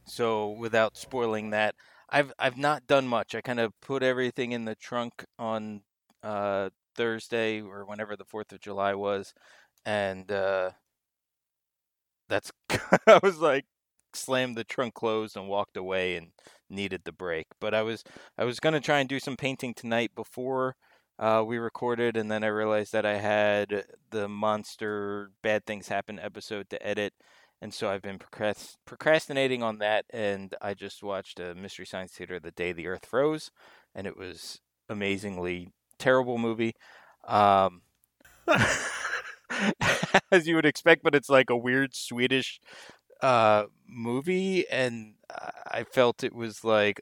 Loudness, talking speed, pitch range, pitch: -28 LUFS, 155 wpm, 100-125 Hz, 110 Hz